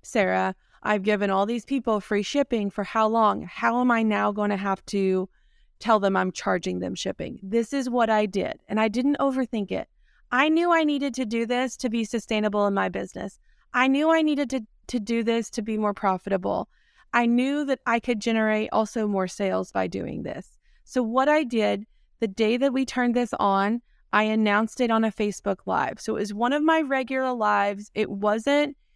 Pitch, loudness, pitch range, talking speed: 225 Hz, -25 LUFS, 205-255 Hz, 205 wpm